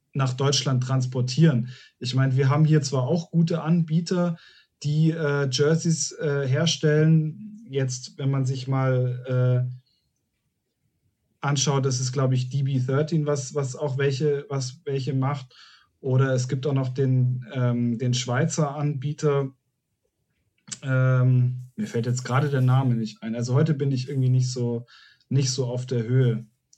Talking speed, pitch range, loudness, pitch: 150 wpm, 125-145 Hz, -24 LUFS, 135 Hz